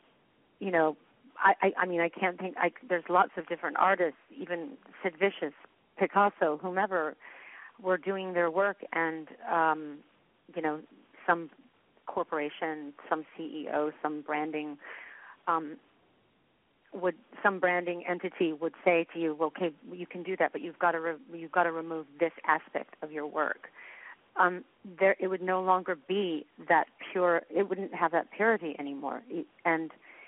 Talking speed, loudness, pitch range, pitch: 155 wpm, -31 LUFS, 160-185 Hz, 175 Hz